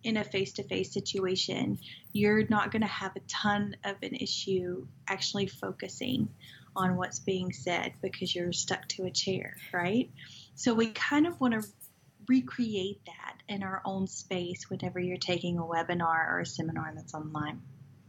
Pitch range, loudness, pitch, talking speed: 175-210 Hz, -32 LUFS, 190 Hz, 170 wpm